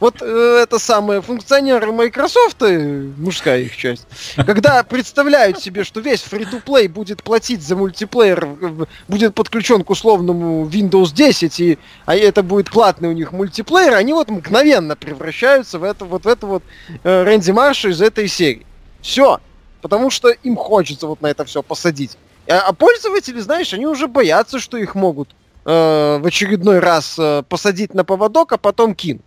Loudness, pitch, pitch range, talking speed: -14 LUFS, 205 Hz, 170-235 Hz, 170 wpm